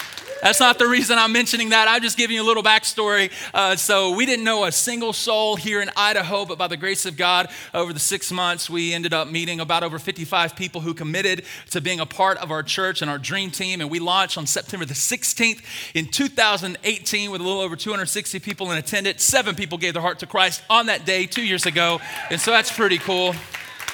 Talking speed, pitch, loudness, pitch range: 230 wpm, 190 Hz, -20 LUFS, 175-215 Hz